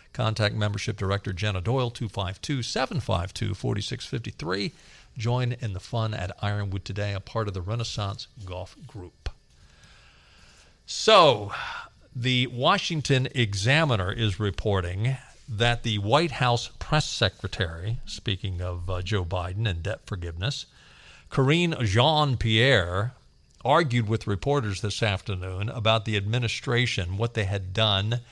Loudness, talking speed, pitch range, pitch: -26 LUFS, 115 wpm, 100-125 Hz, 110 Hz